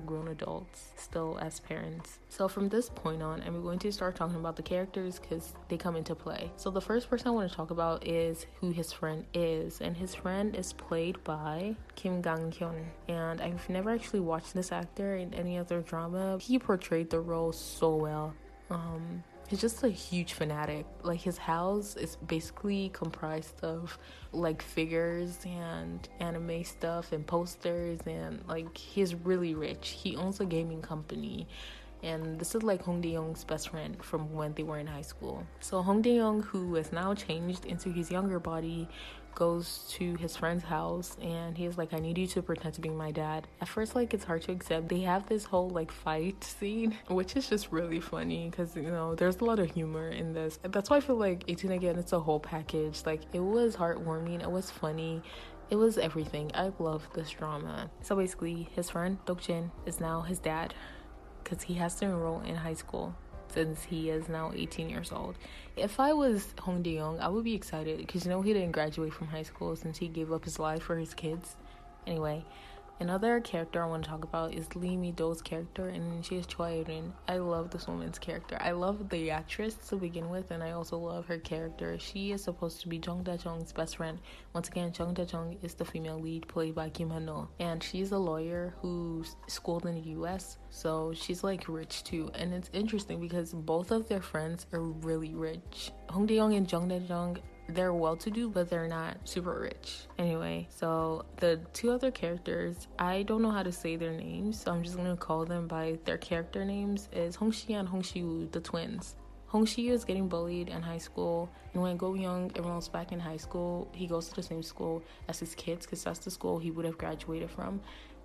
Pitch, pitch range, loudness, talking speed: 170 Hz, 160-185 Hz, -35 LUFS, 205 wpm